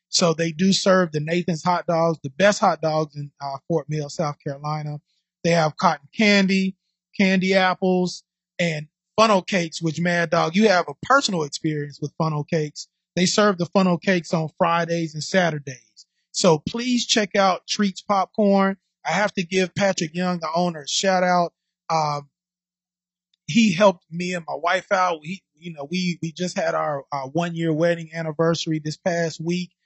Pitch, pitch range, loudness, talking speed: 175 Hz, 160-185 Hz, -22 LUFS, 175 wpm